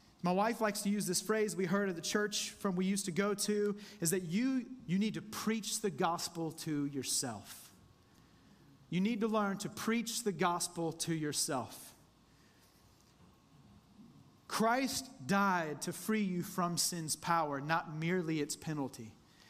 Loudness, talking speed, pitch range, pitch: -35 LUFS, 155 wpm, 155-205 Hz, 180 Hz